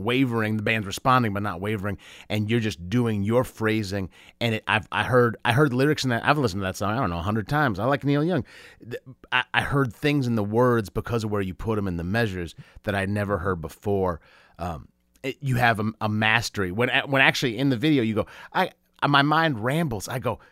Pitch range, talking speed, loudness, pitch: 100-130 Hz, 230 wpm, -24 LUFS, 115 Hz